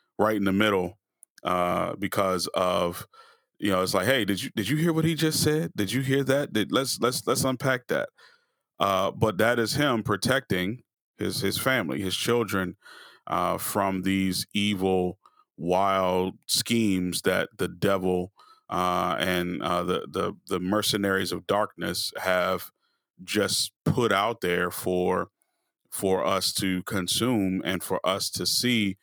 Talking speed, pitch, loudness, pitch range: 155 wpm, 100 Hz, -26 LUFS, 90-120 Hz